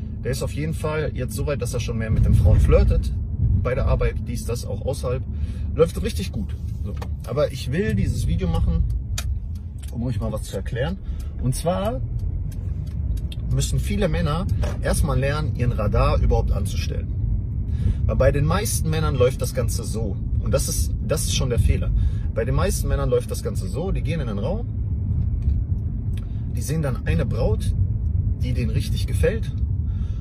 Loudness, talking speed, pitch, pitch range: -24 LUFS, 175 wpm, 100 Hz, 90-110 Hz